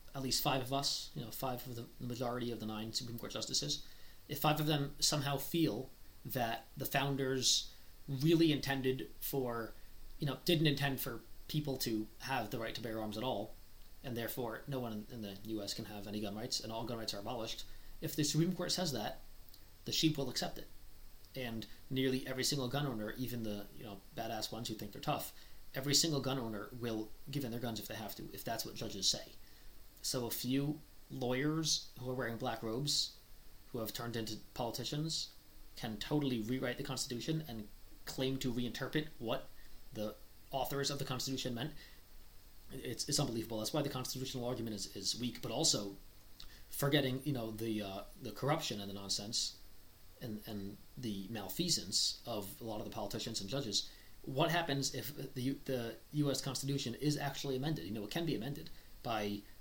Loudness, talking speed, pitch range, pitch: -38 LUFS, 190 wpm, 105-135 Hz, 120 Hz